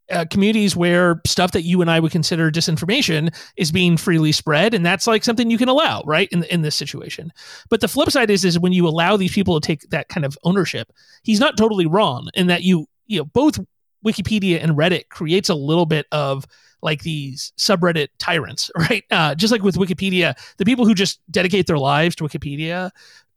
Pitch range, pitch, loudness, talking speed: 160-200 Hz, 175 Hz, -18 LUFS, 210 wpm